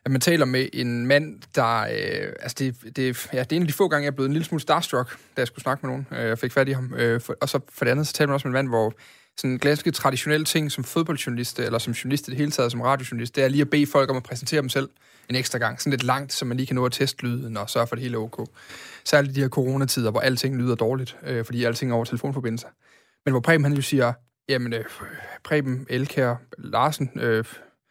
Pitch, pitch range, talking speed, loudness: 130 Hz, 120-145 Hz, 275 wpm, -24 LUFS